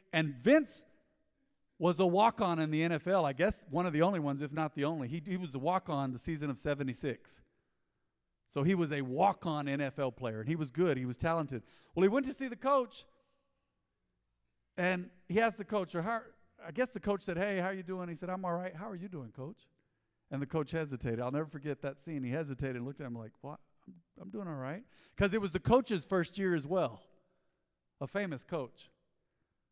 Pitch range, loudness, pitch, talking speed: 140-195 Hz, -34 LUFS, 165 Hz, 230 wpm